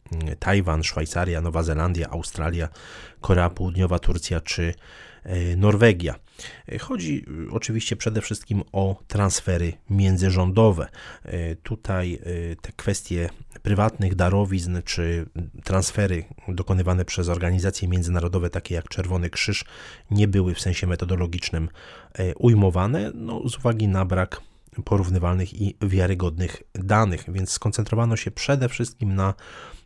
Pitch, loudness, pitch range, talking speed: 95 Hz, -24 LUFS, 85-105 Hz, 105 wpm